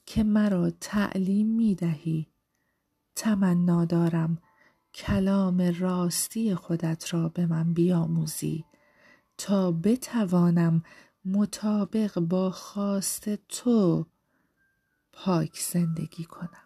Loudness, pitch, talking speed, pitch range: -27 LUFS, 180 Hz, 80 wpm, 170-200 Hz